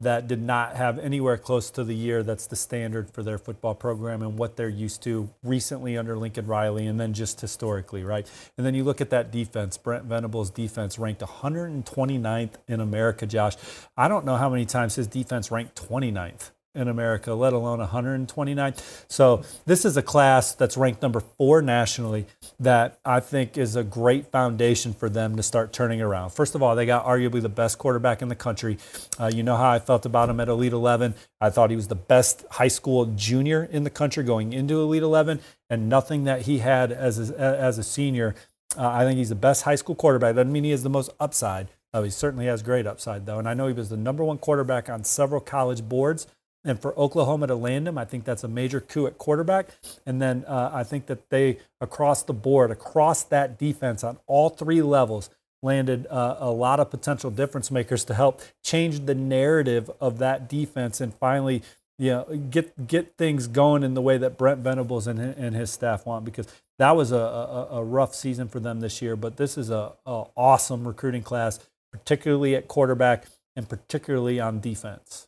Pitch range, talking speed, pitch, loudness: 115-135 Hz, 210 wpm, 125 Hz, -24 LUFS